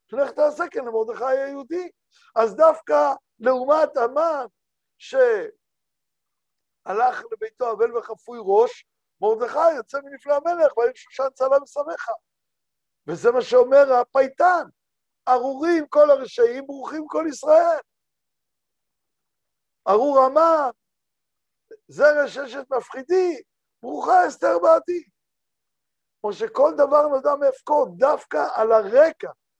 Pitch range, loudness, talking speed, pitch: 265-345 Hz, -20 LUFS, 100 wpm, 290 Hz